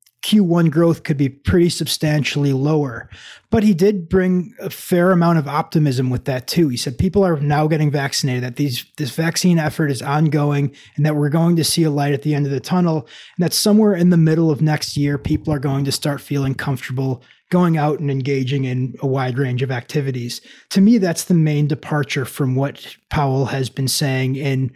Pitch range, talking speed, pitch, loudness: 135-165 Hz, 210 wpm, 150 Hz, -18 LUFS